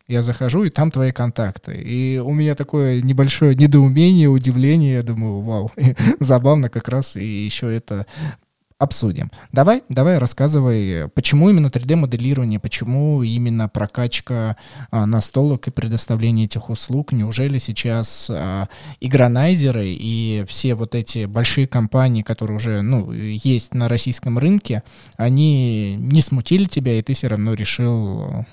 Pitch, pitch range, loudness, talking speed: 125 Hz, 110-135 Hz, -18 LUFS, 135 wpm